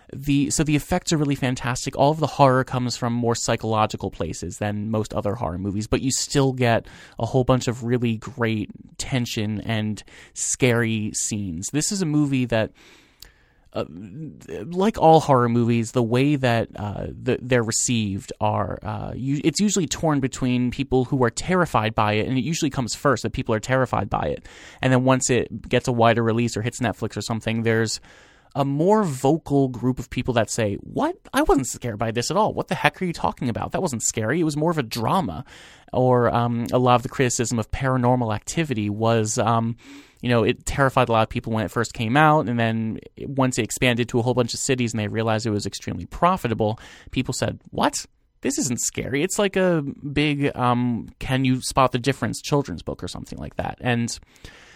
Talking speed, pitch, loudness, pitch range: 205 wpm, 125 Hz, -22 LUFS, 110-135 Hz